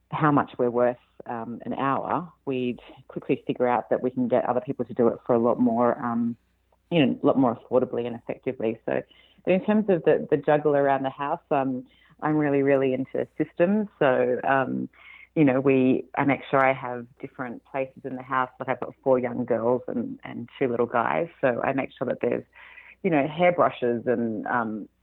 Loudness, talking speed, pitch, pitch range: -25 LUFS, 210 wpm, 130 Hz, 120-140 Hz